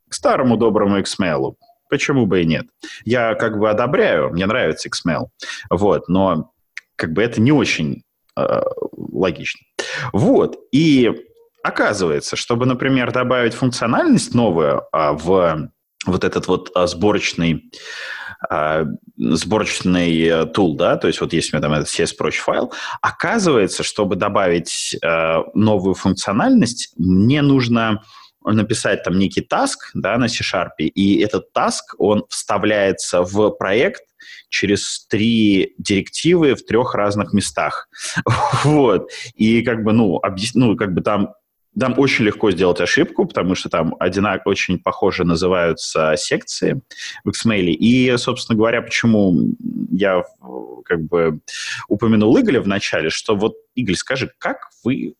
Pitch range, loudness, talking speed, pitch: 90-125 Hz, -17 LUFS, 135 wpm, 105 Hz